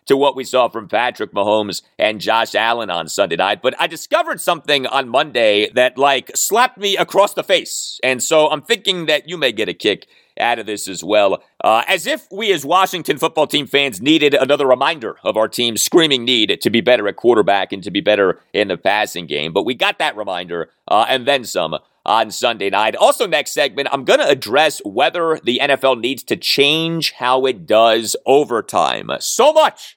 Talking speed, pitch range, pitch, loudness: 205 wpm, 115-165 Hz, 140 Hz, -16 LUFS